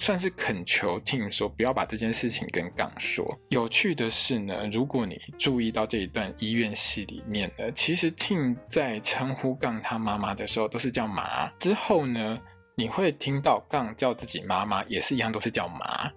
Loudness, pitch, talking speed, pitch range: -26 LUFS, 115 Hz, 290 characters per minute, 110-130 Hz